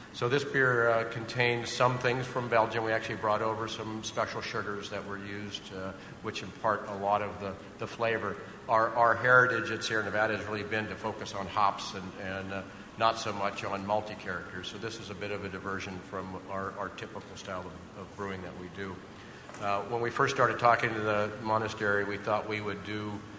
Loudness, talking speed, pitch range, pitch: -31 LUFS, 215 wpm, 100-115 Hz, 105 Hz